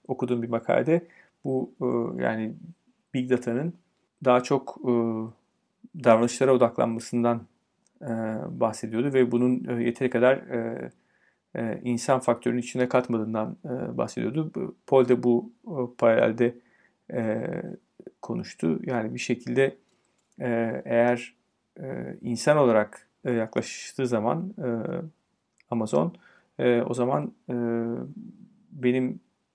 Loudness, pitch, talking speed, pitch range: -26 LUFS, 125 Hz, 75 wpm, 115-140 Hz